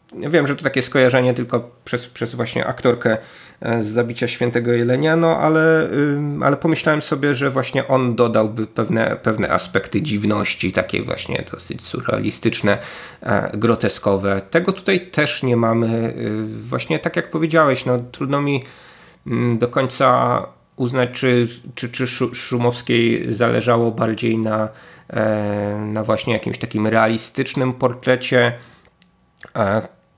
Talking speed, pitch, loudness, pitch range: 120 wpm, 120 Hz, -19 LUFS, 115-135 Hz